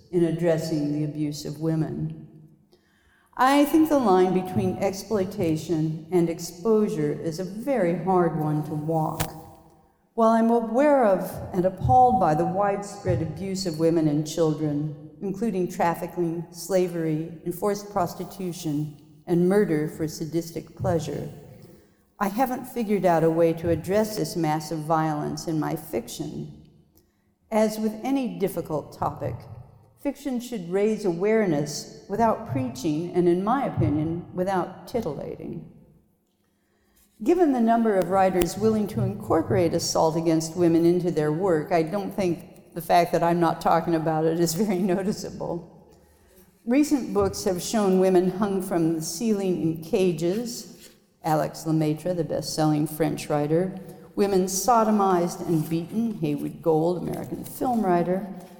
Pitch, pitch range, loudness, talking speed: 175 Hz, 160-195 Hz, -24 LUFS, 135 wpm